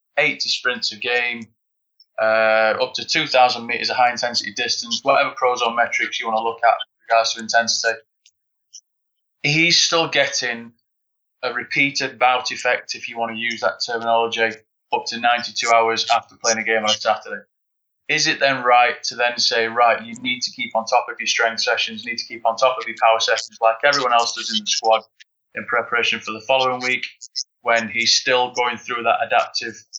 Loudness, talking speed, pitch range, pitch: -19 LUFS, 200 wpm, 115-130 Hz, 120 Hz